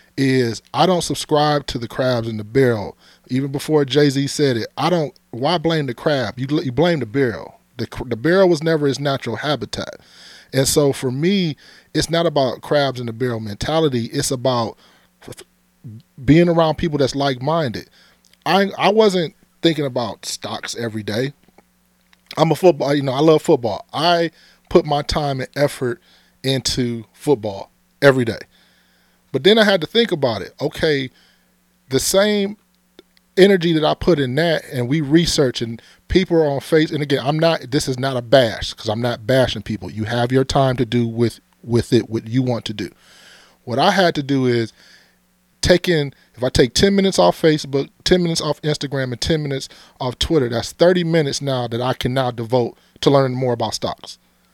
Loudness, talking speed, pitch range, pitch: -18 LUFS, 190 wpm, 120-160 Hz, 135 Hz